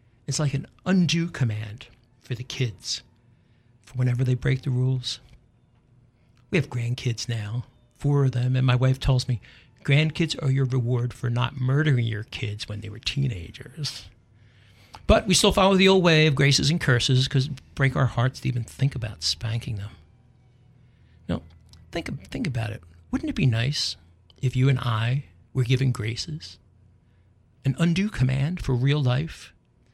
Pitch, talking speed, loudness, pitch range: 125 Hz, 165 wpm, -24 LUFS, 115-135 Hz